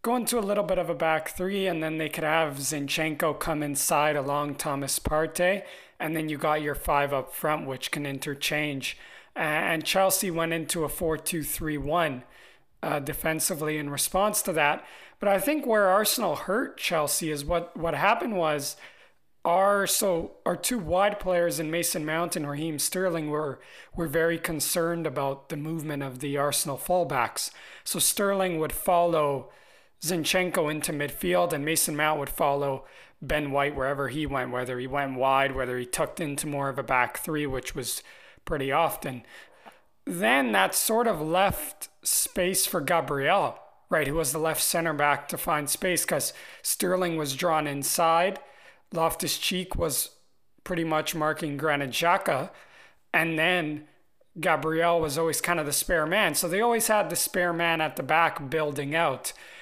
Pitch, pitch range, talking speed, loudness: 160 Hz, 145-175 Hz, 165 wpm, -26 LUFS